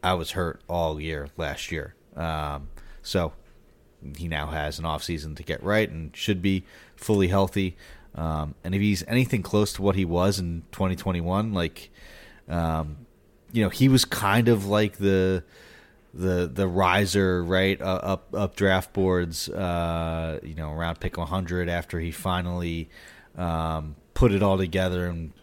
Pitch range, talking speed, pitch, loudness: 80-95 Hz, 160 wpm, 90 Hz, -26 LUFS